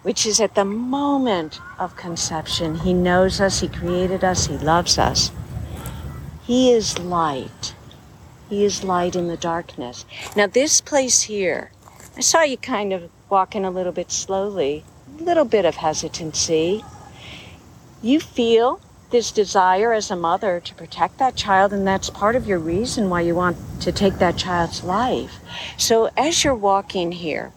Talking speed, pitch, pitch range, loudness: 160 wpm, 185 Hz, 165-215 Hz, -20 LUFS